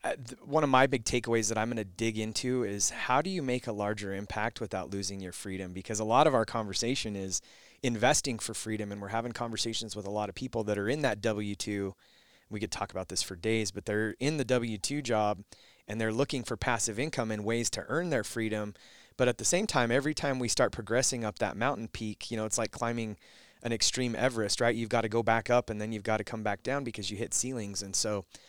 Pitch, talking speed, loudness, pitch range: 110 Hz, 240 wpm, -31 LUFS, 105-120 Hz